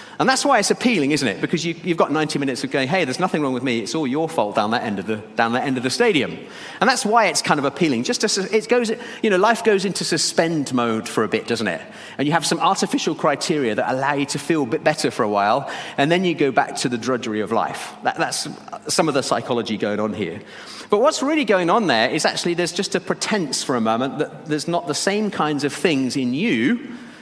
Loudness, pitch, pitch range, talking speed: -20 LUFS, 170 Hz, 140-220 Hz, 265 wpm